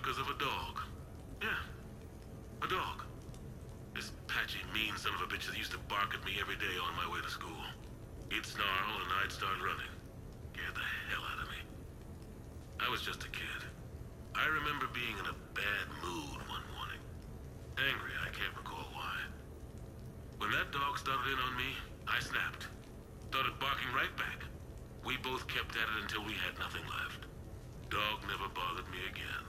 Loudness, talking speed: -38 LUFS, 175 wpm